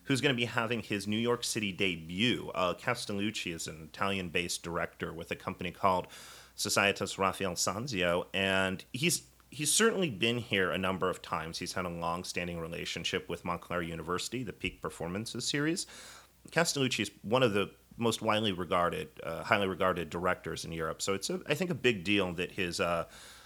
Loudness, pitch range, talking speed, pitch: -32 LUFS, 90-120 Hz, 180 wpm, 100 Hz